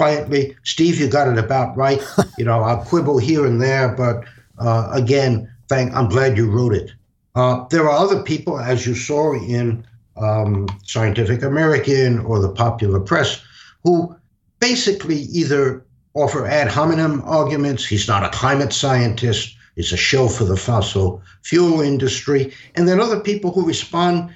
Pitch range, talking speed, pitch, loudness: 115-150 Hz, 160 wpm, 130 Hz, -18 LUFS